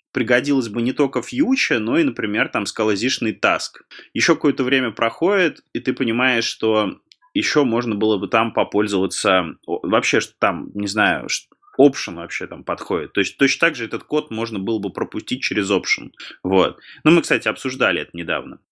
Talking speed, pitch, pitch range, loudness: 175 wpm, 120 Hz, 110-140 Hz, -19 LUFS